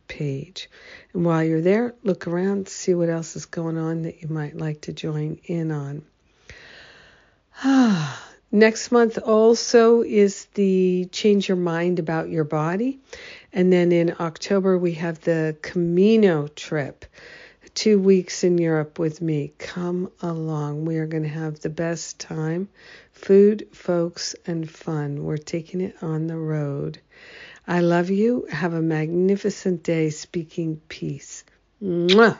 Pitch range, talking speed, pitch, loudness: 160-195 Hz, 145 wpm, 175 Hz, -22 LUFS